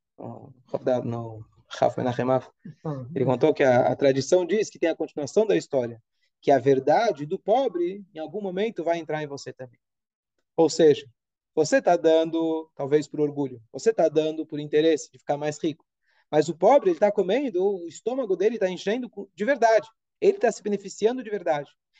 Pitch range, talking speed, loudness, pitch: 135-200 Hz, 165 wpm, -24 LUFS, 155 Hz